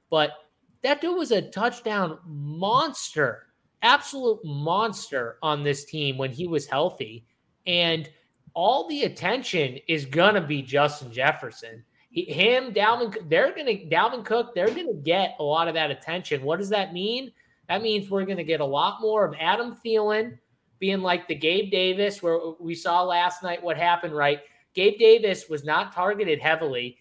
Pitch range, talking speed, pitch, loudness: 150-220 Hz, 170 wpm, 175 Hz, -24 LUFS